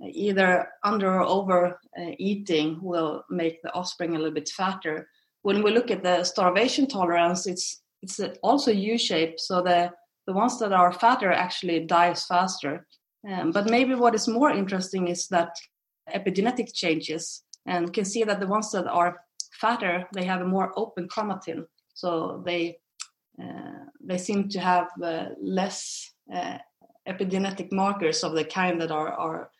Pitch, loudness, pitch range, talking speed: 180 Hz, -26 LUFS, 170-200 Hz, 160 wpm